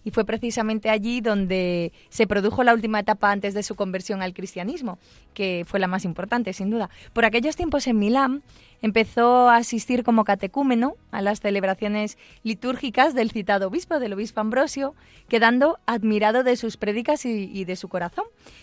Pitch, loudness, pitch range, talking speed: 220 Hz, -23 LUFS, 200-240 Hz, 165 wpm